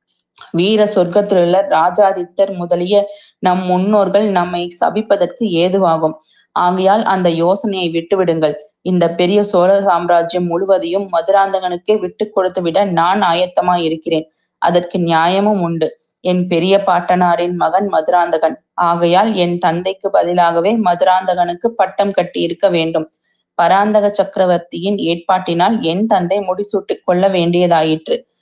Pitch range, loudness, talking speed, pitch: 170-200 Hz, -14 LUFS, 105 wpm, 180 Hz